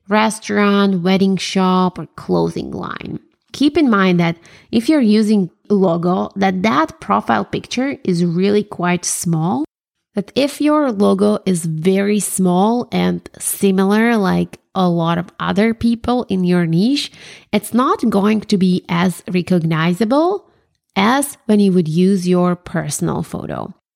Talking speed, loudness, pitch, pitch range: 140 wpm, -16 LUFS, 195 Hz, 180-220 Hz